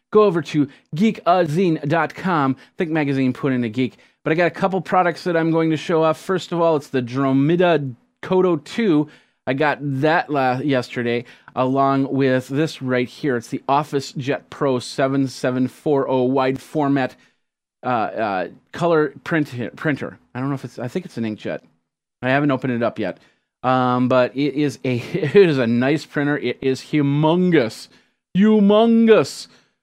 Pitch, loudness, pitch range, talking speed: 140 Hz, -20 LUFS, 130-165 Hz, 165 wpm